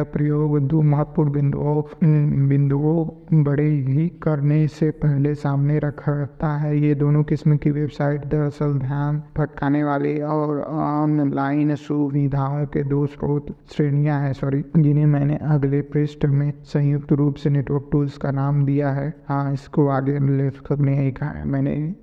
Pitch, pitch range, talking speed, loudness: 145 Hz, 140-150 Hz, 140 wpm, -21 LUFS